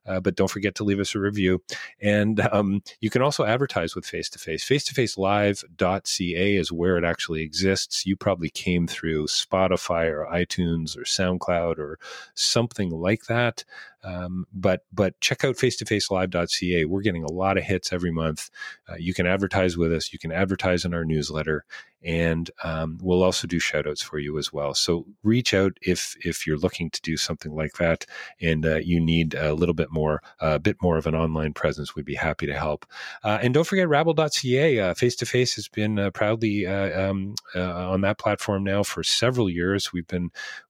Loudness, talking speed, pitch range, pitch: -24 LUFS, 200 wpm, 85-105 Hz, 95 Hz